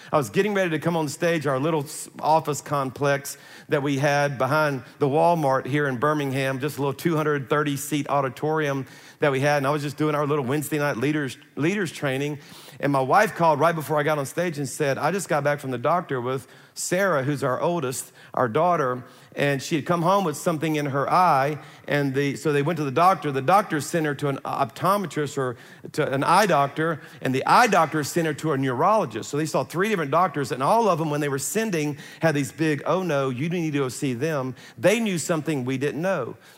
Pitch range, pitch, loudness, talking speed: 140-160 Hz, 150 Hz, -23 LUFS, 225 wpm